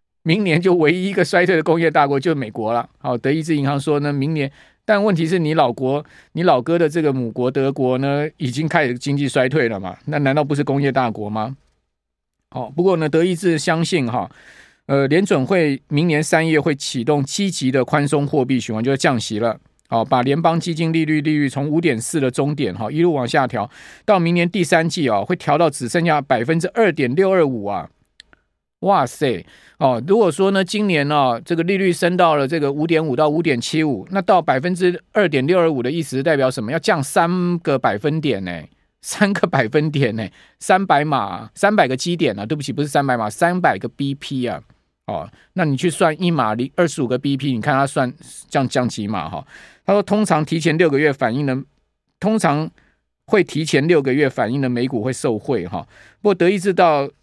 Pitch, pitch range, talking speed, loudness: 150 Hz, 130-170 Hz, 305 characters per minute, -18 LUFS